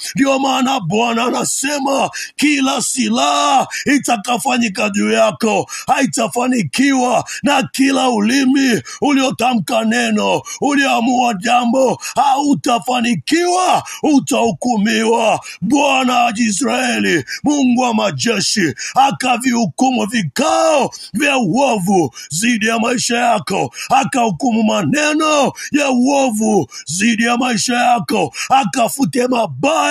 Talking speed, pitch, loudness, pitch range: 85 wpm, 245 Hz, -15 LUFS, 230-270 Hz